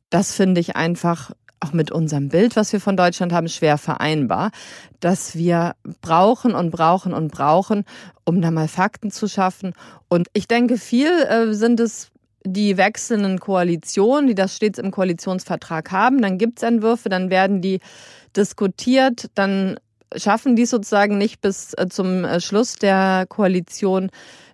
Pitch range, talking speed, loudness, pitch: 175-215 Hz, 150 wpm, -19 LUFS, 190 Hz